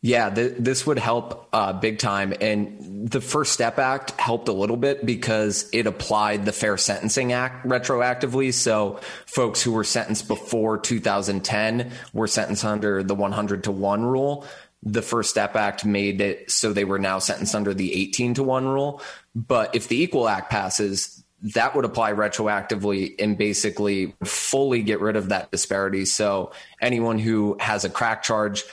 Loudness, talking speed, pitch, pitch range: -23 LUFS, 170 wpm, 110 Hz, 100-120 Hz